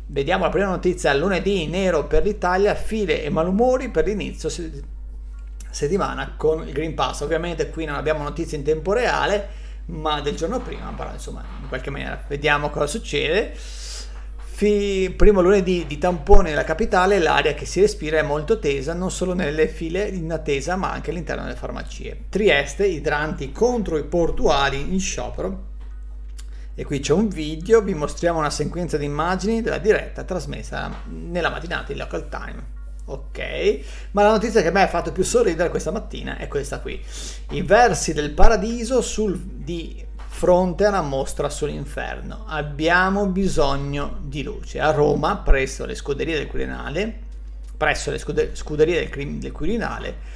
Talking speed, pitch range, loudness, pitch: 160 wpm, 145-200 Hz, -22 LUFS, 165 Hz